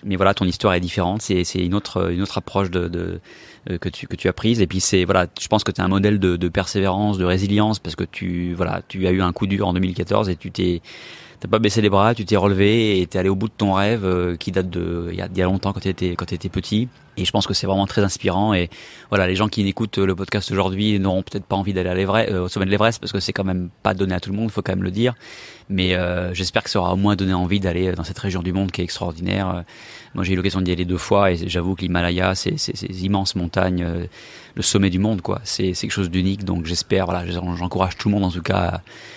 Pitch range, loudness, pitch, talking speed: 90-100 Hz, -21 LUFS, 95 Hz, 280 wpm